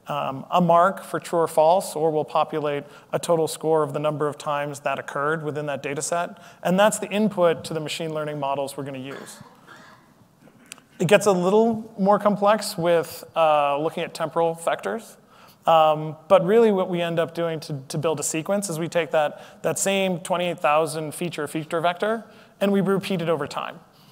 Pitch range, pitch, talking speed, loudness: 155-190 Hz, 165 Hz, 195 wpm, -23 LUFS